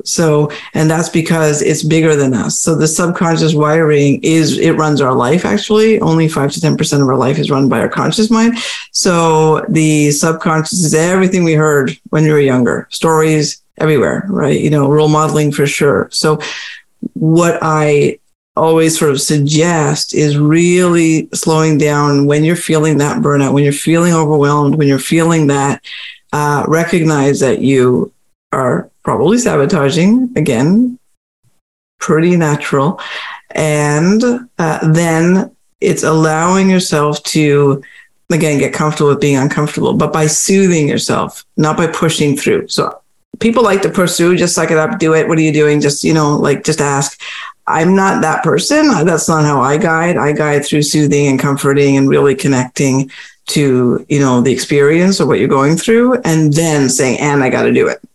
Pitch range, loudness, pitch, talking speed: 145-170 Hz, -12 LUFS, 155 Hz, 170 wpm